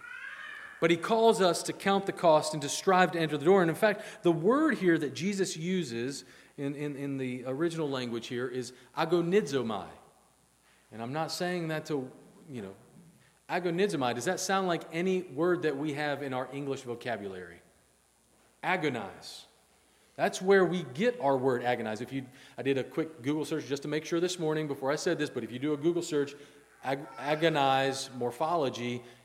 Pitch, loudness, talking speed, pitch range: 150 Hz, -30 LUFS, 185 wpm, 135-175 Hz